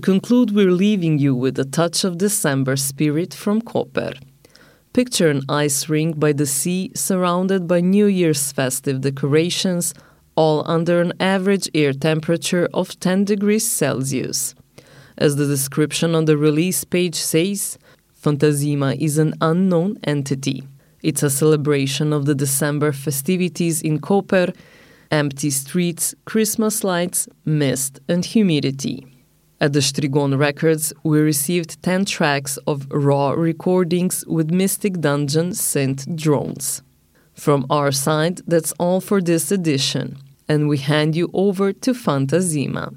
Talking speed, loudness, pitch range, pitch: 135 wpm, -19 LUFS, 145-180 Hz, 155 Hz